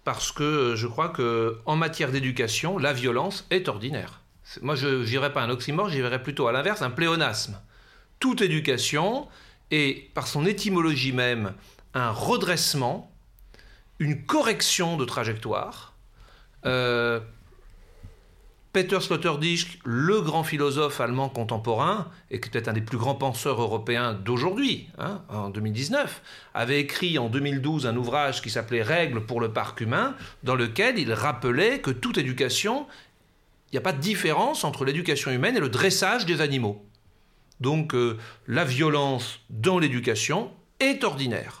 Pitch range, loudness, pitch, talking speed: 120-160 Hz, -26 LUFS, 135 Hz, 140 wpm